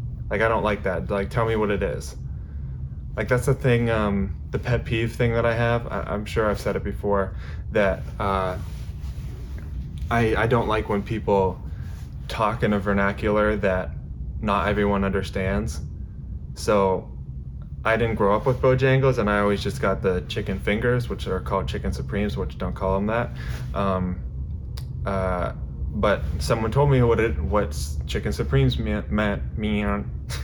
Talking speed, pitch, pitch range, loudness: 170 wpm, 100 Hz, 75-110 Hz, -24 LUFS